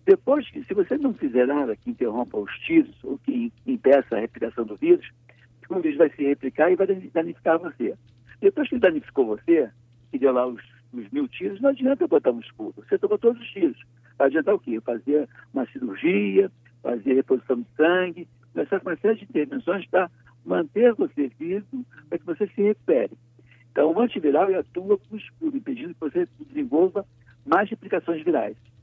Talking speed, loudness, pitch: 180 wpm, -24 LUFS, 185 Hz